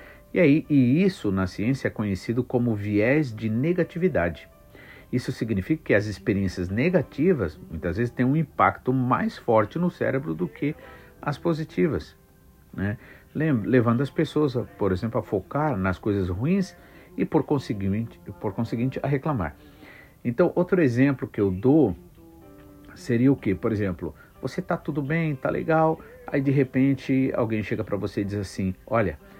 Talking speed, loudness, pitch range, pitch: 155 wpm, -25 LUFS, 100-145 Hz, 125 Hz